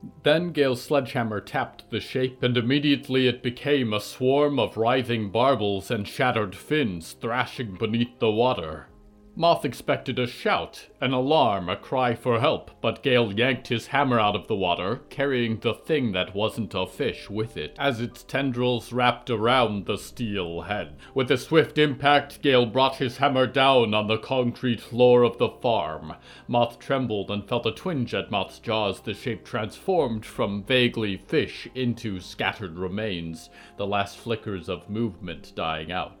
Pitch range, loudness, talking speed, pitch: 105-130 Hz, -25 LUFS, 165 wpm, 120 Hz